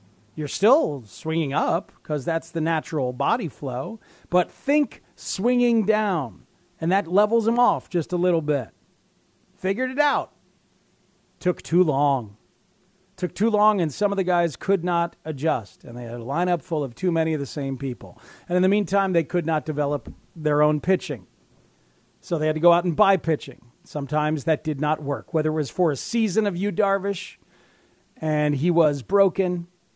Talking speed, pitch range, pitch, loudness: 180 wpm, 150-190 Hz, 165 Hz, -23 LUFS